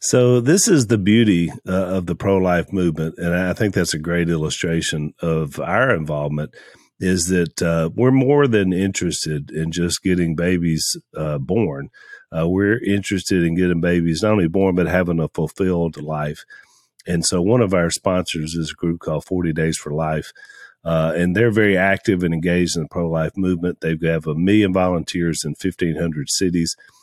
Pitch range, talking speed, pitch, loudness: 80-95 Hz, 180 wpm, 85 Hz, -19 LUFS